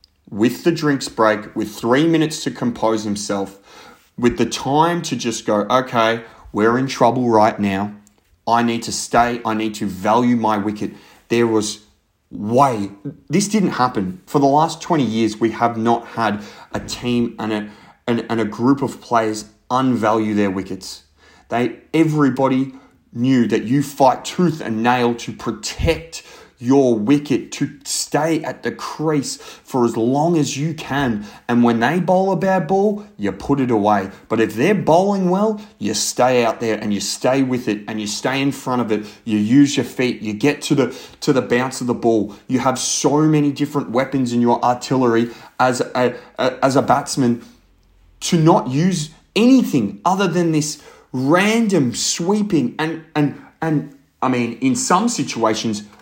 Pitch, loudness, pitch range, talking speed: 125 Hz, -18 LUFS, 110-145 Hz, 175 wpm